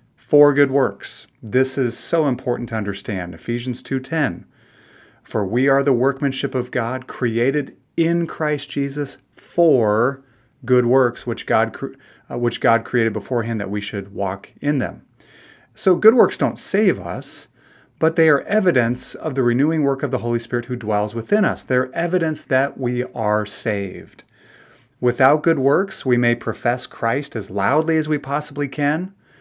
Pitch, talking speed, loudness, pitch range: 130 Hz, 165 wpm, -20 LUFS, 120-145 Hz